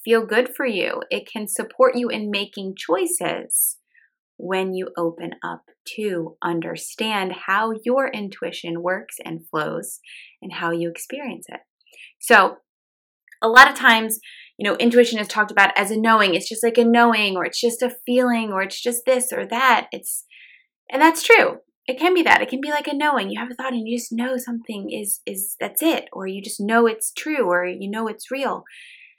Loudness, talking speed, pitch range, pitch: -20 LUFS, 195 wpm, 195-260 Hz, 230 Hz